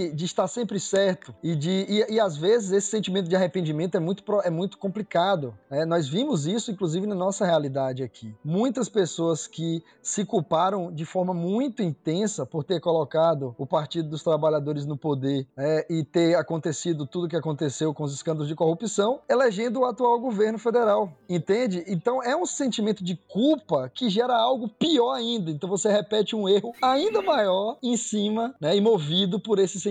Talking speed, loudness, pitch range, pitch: 185 wpm, -25 LUFS, 160-220 Hz, 190 Hz